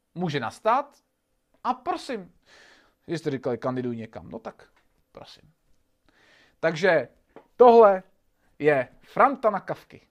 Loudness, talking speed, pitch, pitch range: -23 LUFS, 100 wpm, 190 Hz, 145-245 Hz